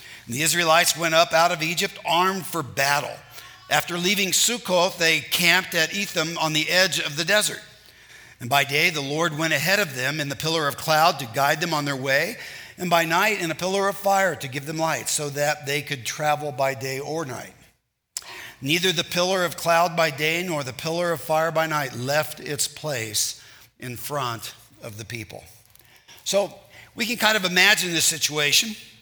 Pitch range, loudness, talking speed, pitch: 140-175 Hz, -22 LUFS, 195 wpm, 160 Hz